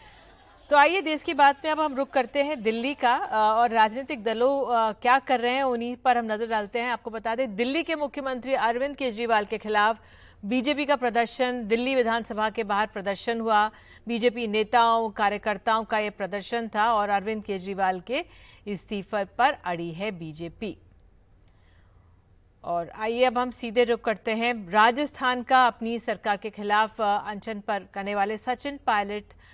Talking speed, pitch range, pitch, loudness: 165 wpm, 210-250 Hz, 225 Hz, -25 LUFS